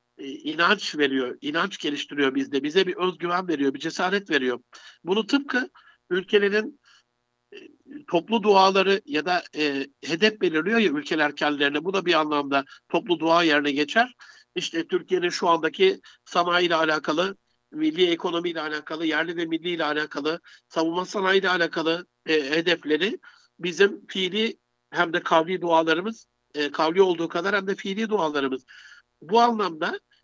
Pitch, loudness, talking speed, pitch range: 175 Hz, -24 LUFS, 140 wpm, 150-205 Hz